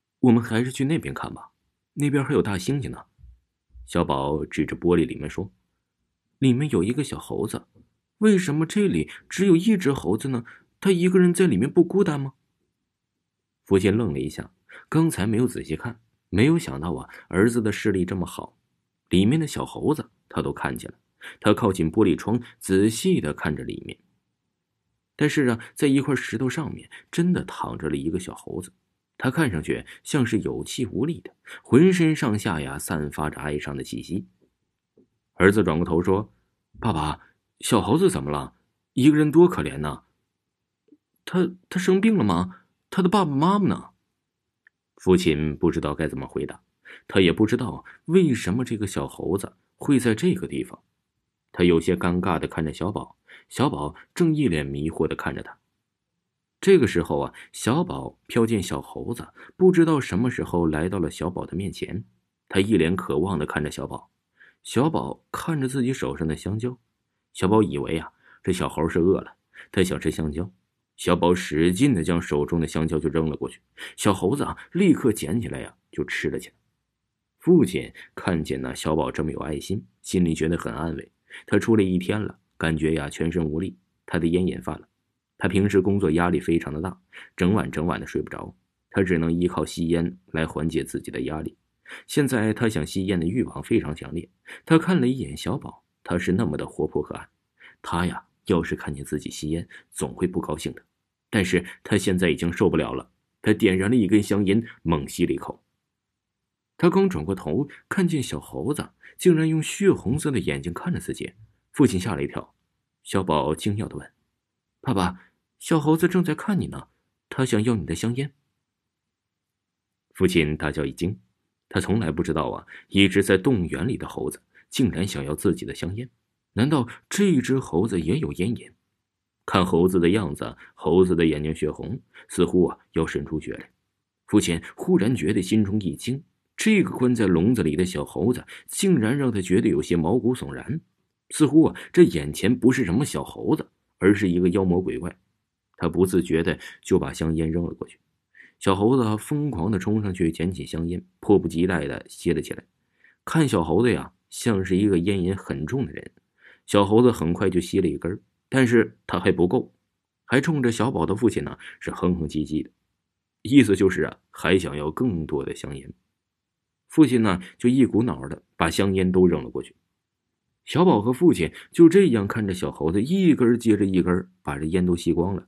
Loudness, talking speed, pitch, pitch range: -23 LUFS, 265 characters per minute, 95 Hz, 80-130 Hz